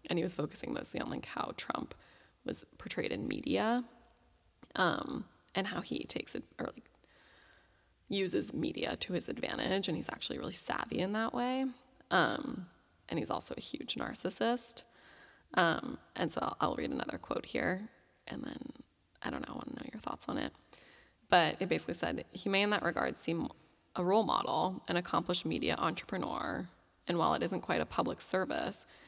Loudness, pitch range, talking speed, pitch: -35 LUFS, 195-255 Hz, 180 wpm, 235 Hz